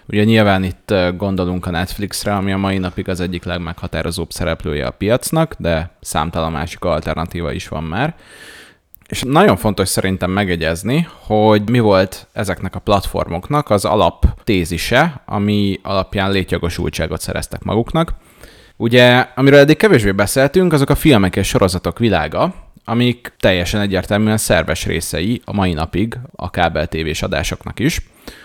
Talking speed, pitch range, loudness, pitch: 135 wpm, 85-110 Hz, -16 LUFS, 95 Hz